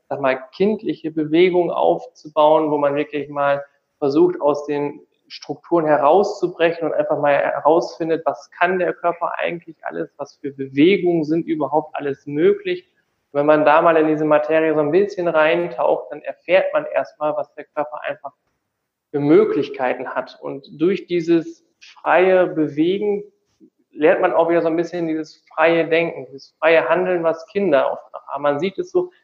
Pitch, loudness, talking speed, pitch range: 160 Hz, -19 LUFS, 165 wpm, 150-180 Hz